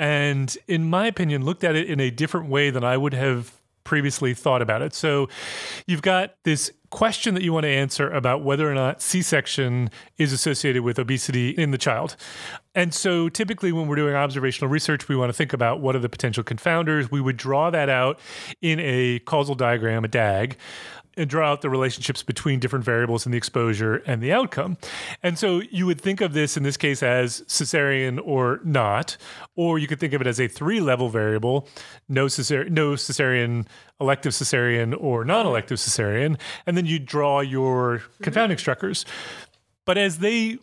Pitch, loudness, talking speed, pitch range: 140 Hz, -23 LUFS, 190 wpm, 125-160 Hz